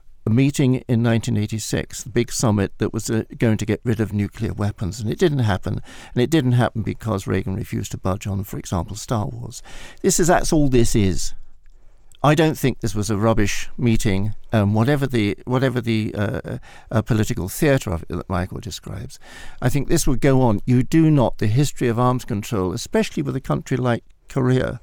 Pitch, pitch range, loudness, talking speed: 115 Hz, 105-130 Hz, -21 LUFS, 205 wpm